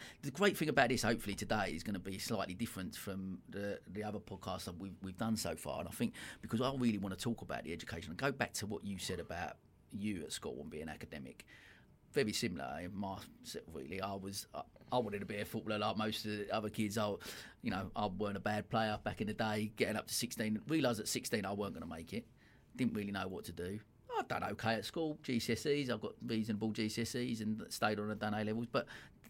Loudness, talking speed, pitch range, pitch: -40 LUFS, 245 wpm, 100-115 Hz, 105 Hz